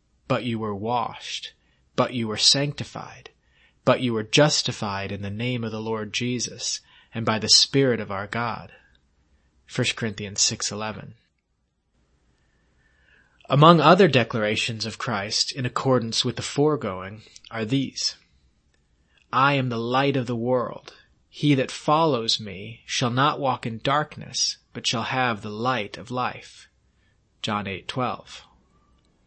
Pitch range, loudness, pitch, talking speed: 100-125 Hz, -23 LUFS, 115 Hz, 135 wpm